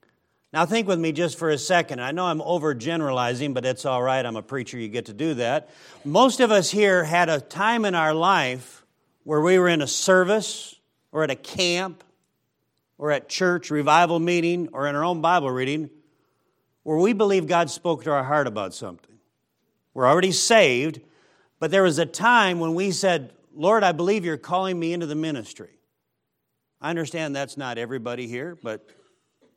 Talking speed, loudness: 185 wpm, -22 LUFS